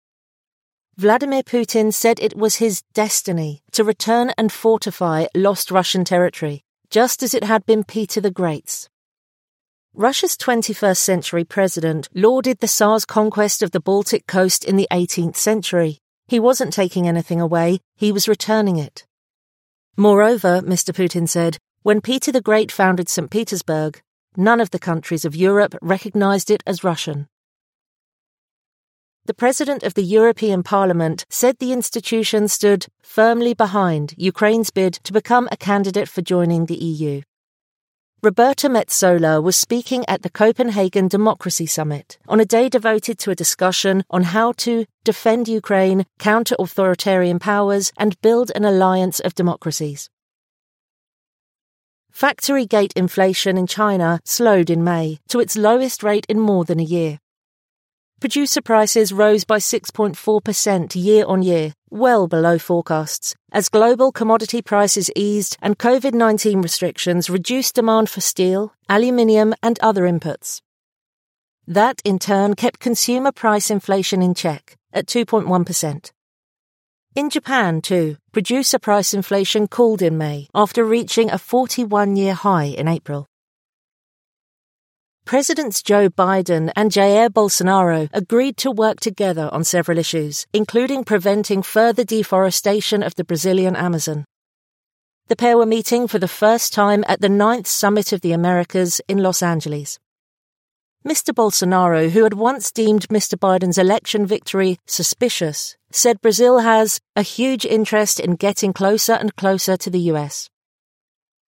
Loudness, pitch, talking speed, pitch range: -17 LUFS, 205 Hz, 140 wpm, 180-225 Hz